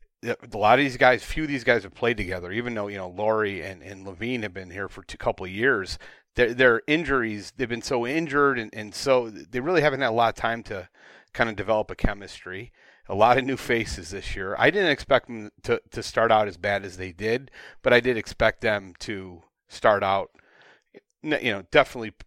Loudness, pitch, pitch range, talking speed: -24 LUFS, 110 Hz, 100-120 Hz, 225 wpm